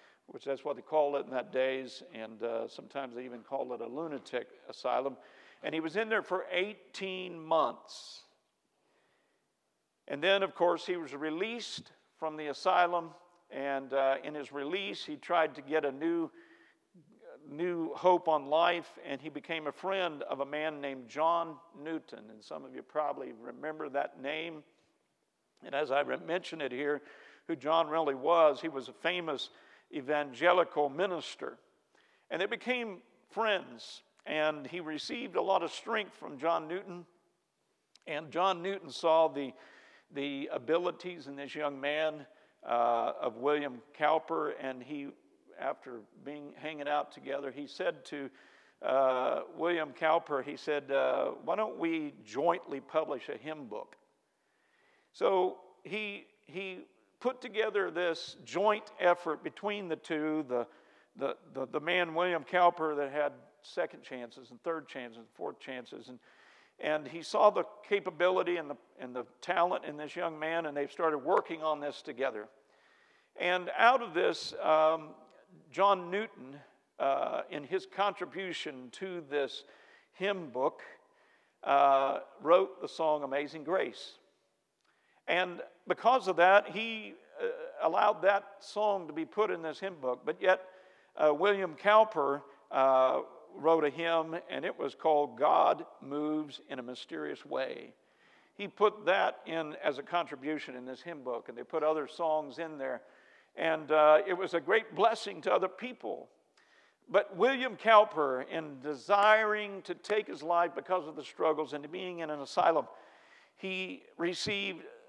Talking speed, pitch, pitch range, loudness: 155 wpm, 165 Hz, 145-190 Hz, -32 LUFS